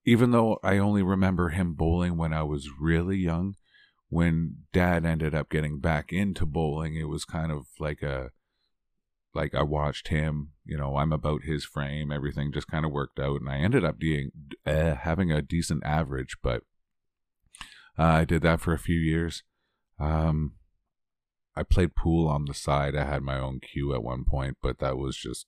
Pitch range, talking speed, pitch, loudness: 70-85 Hz, 190 wpm, 75 Hz, -28 LUFS